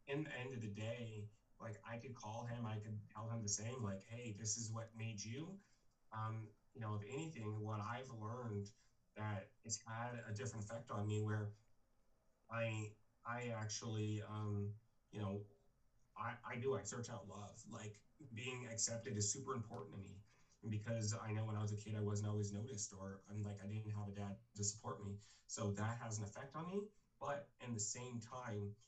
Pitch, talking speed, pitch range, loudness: 110 Hz, 200 wpm, 105-120 Hz, -47 LUFS